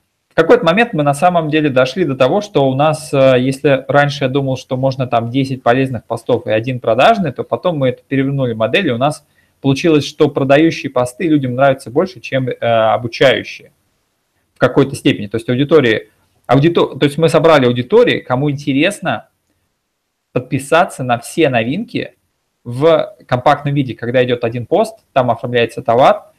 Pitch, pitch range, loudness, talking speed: 135 Hz, 125-155 Hz, -14 LUFS, 165 wpm